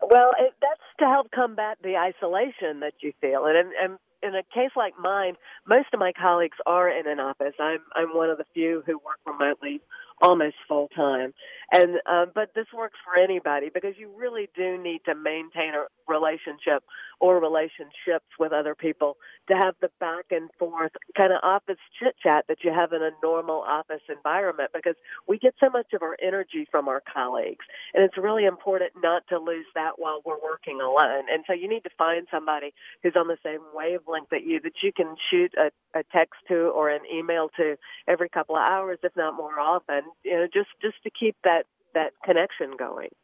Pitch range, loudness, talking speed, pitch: 160-195 Hz, -25 LUFS, 205 wpm, 175 Hz